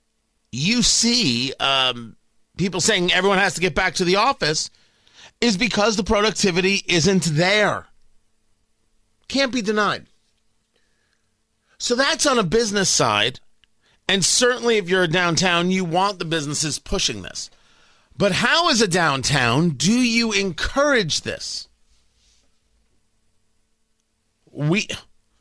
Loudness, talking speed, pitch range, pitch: -19 LUFS, 120 wpm, 145-215 Hz, 185 Hz